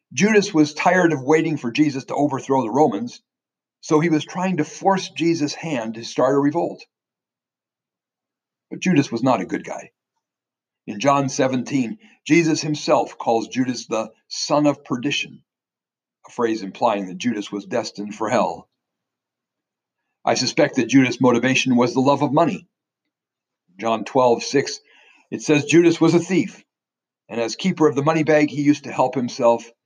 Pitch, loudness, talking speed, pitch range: 140 Hz, -20 LUFS, 165 wpm, 120-155 Hz